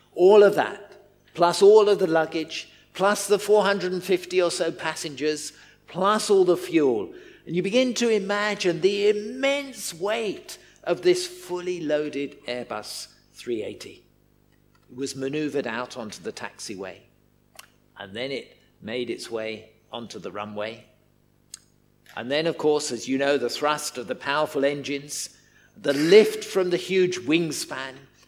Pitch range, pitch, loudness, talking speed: 140-205 Hz, 165 Hz, -24 LUFS, 140 wpm